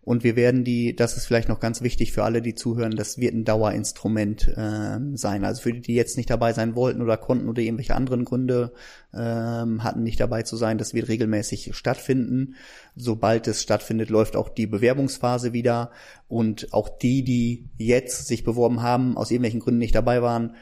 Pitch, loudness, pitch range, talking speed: 115 Hz, -24 LUFS, 110-120 Hz, 195 wpm